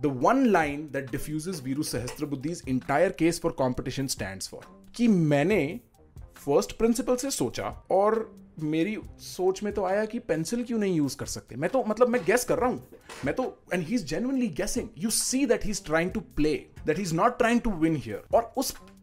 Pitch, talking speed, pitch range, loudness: 180 Hz, 195 wpm, 150-225 Hz, -27 LUFS